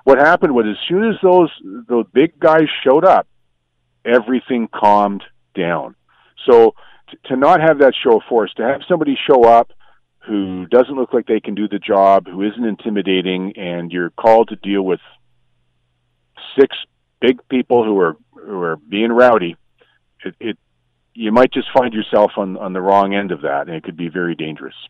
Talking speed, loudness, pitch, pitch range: 185 wpm, -15 LUFS, 100 Hz, 85-125 Hz